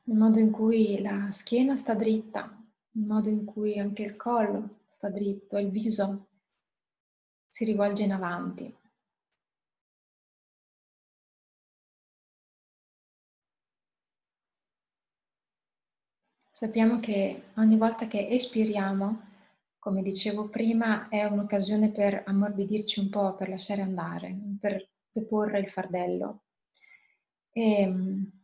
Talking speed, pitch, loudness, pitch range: 95 wpm, 210 Hz, -28 LUFS, 200-220 Hz